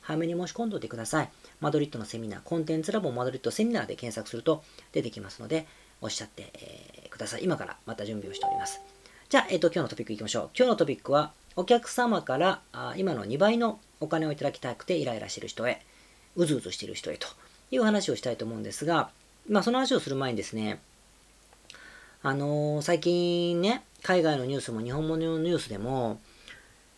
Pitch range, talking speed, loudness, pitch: 120-180 Hz, 435 characters per minute, -30 LUFS, 155 Hz